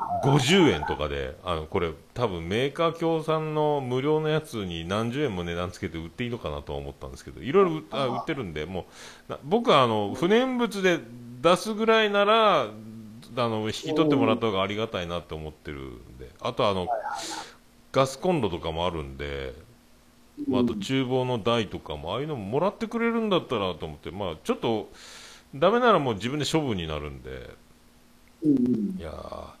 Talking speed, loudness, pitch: 355 characters per minute, -26 LUFS, 120 Hz